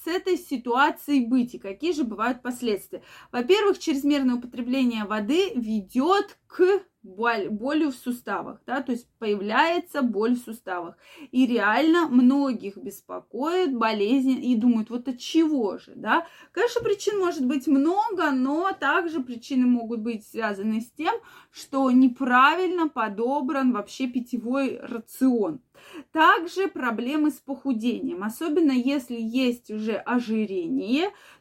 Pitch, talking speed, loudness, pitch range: 260 Hz, 125 wpm, -24 LUFS, 235-315 Hz